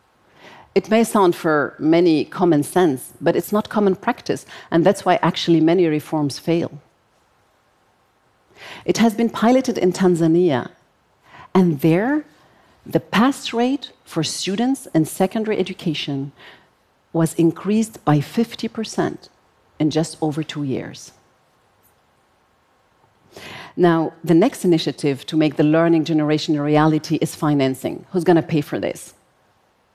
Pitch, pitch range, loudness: 170 Hz, 155-205 Hz, -19 LUFS